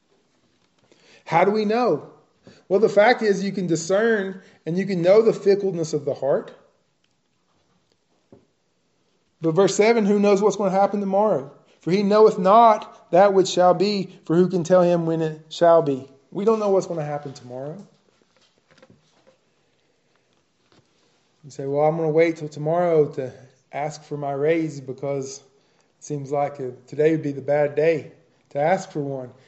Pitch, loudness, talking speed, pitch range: 170 Hz, -20 LUFS, 170 wpm, 145-200 Hz